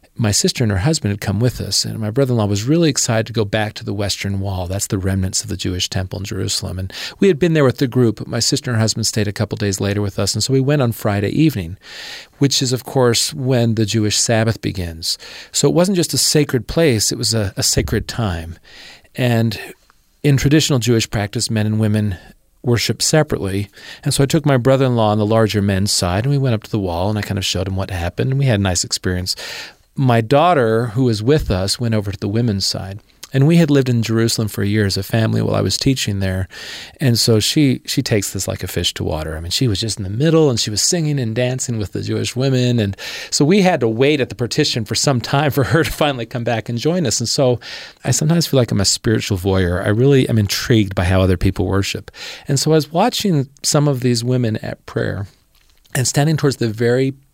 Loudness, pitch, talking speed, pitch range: -17 LUFS, 115 Hz, 255 wpm, 100-135 Hz